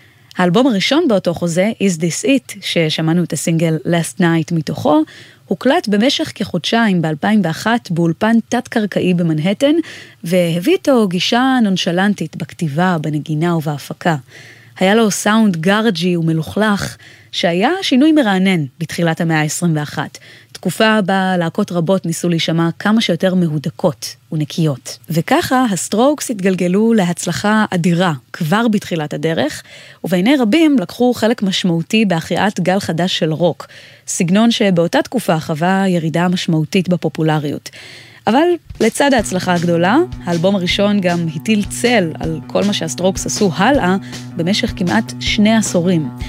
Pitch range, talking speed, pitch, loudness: 165-215 Hz, 120 wpm, 180 Hz, -15 LUFS